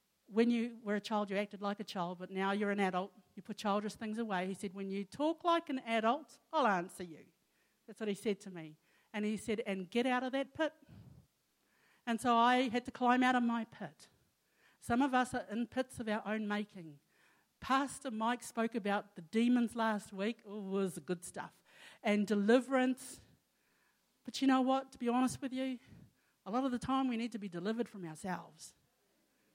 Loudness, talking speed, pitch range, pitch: -36 LUFS, 205 wpm, 200-250 Hz, 225 Hz